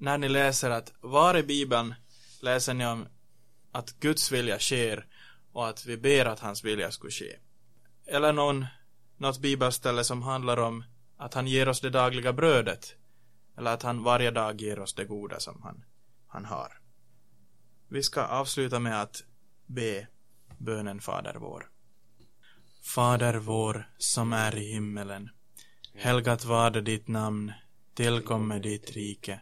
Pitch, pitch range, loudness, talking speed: 120 Hz, 110-125 Hz, -29 LUFS, 145 wpm